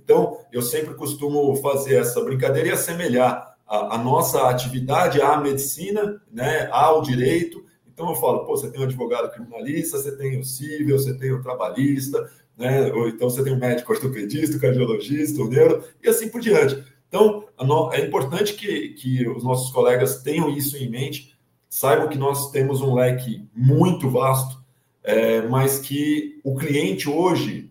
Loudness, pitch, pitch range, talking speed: -21 LUFS, 135 Hz, 130-150 Hz, 165 wpm